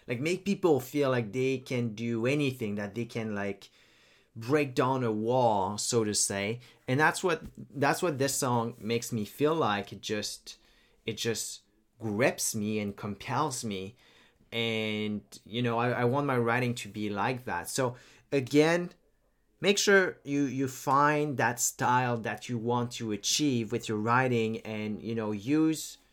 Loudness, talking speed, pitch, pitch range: -30 LUFS, 170 wpm, 120 Hz, 110-135 Hz